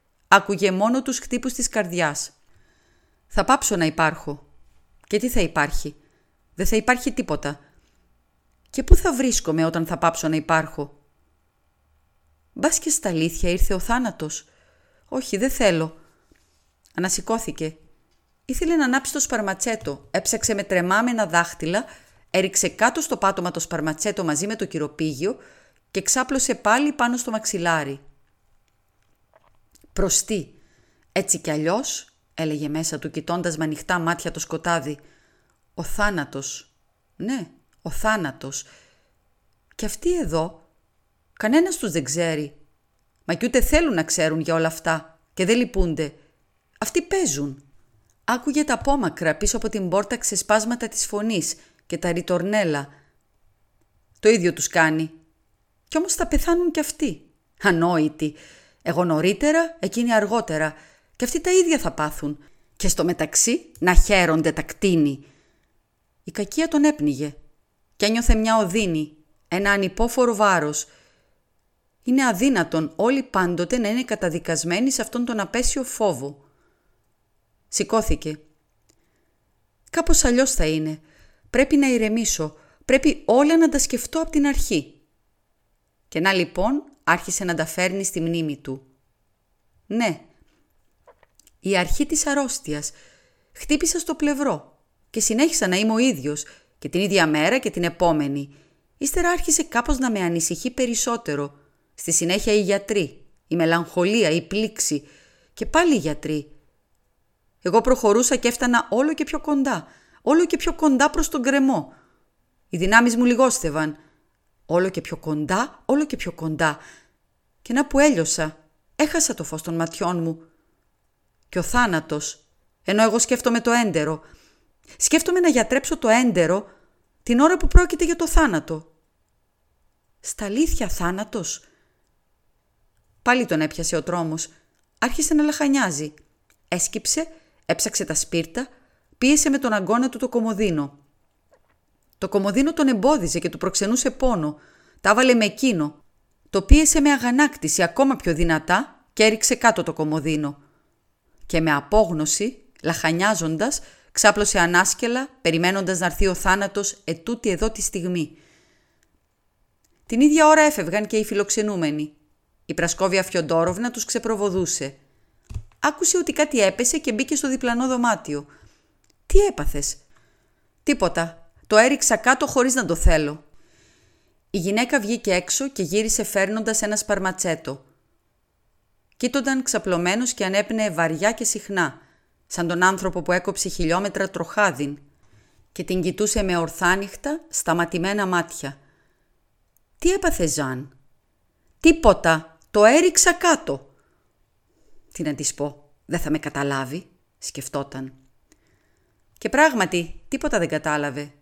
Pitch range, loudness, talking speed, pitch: 155-245 Hz, -21 LUFS, 130 wpm, 190 Hz